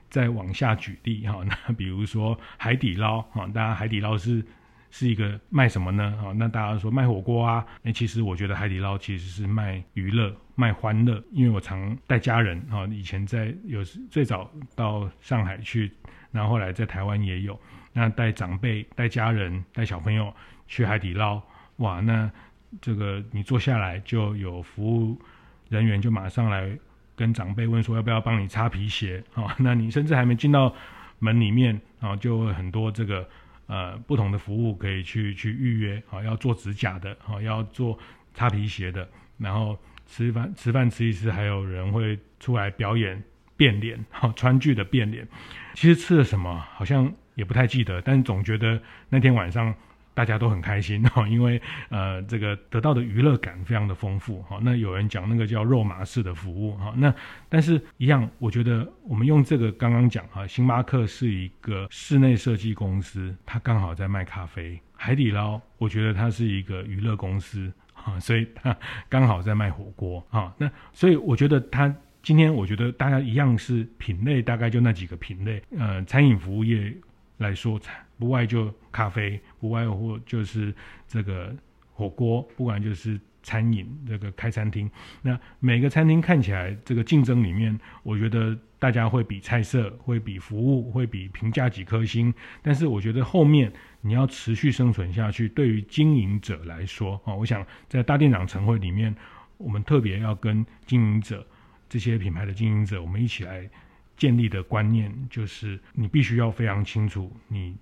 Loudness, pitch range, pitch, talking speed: -25 LUFS, 100-120 Hz, 110 Hz, 265 characters per minute